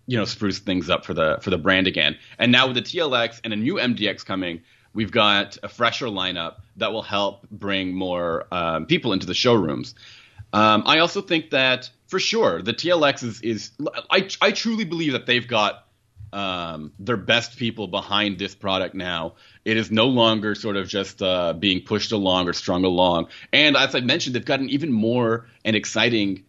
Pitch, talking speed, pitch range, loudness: 105 Hz, 195 wpm, 100-120 Hz, -21 LUFS